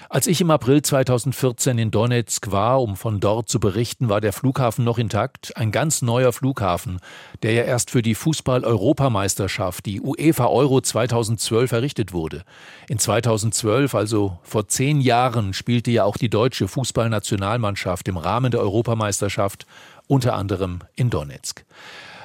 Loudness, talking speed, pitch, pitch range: -21 LUFS, 150 wpm, 115 Hz, 105-130 Hz